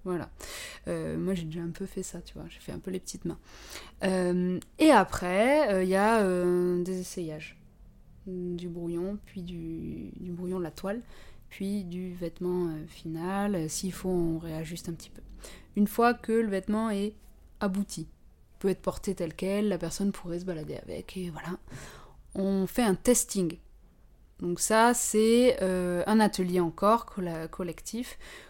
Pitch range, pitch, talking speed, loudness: 175-200 Hz, 185 Hz, 170 wpm, -29 LUFS